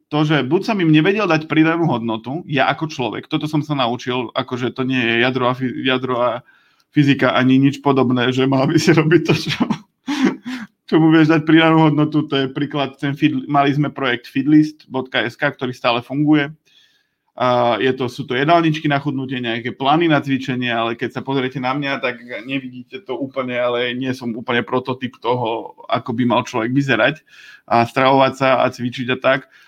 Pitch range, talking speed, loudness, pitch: 125-155 Hz, 180 wpm, -17 LUFS, 135 Hz